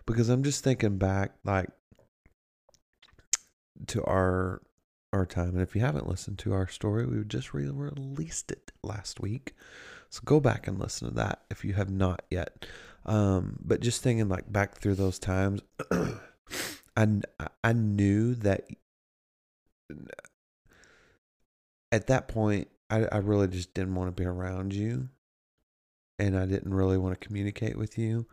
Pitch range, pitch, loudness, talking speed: 95-115 Hz, 100 Hz, -30 LUFS, 155 wpm